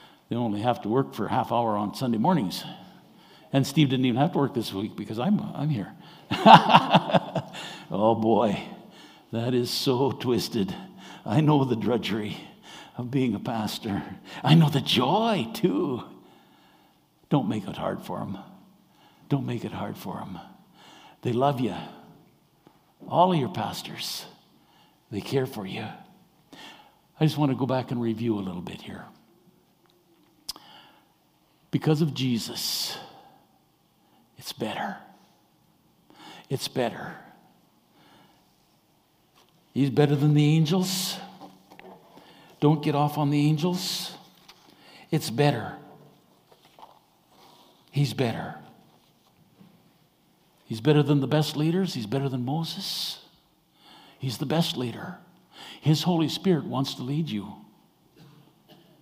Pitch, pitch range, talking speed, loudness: 150 Hz, 130-165 Hz, 125 wpm, -25 LUFS